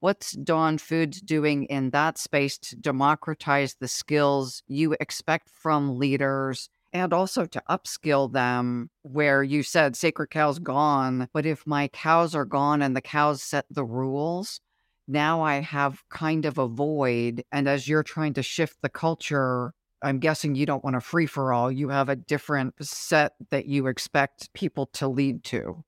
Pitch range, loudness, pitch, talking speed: 135-155 Hz, -26 LUFS, 145 Hz, 170 wpm